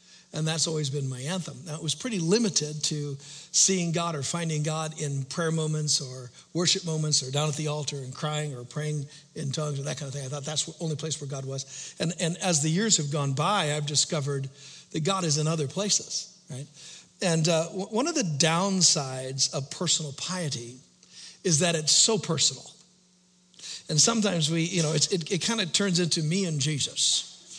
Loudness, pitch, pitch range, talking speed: -26 LUFS, 155 Hz, 145-175 Hz, 205 wpm